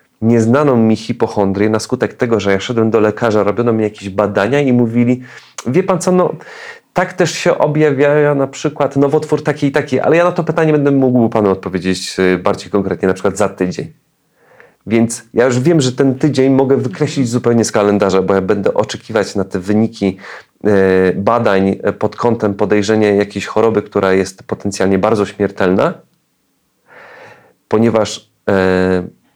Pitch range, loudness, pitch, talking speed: 100-135 Hz, -14 LUFS, 110 Hz, 155 wpm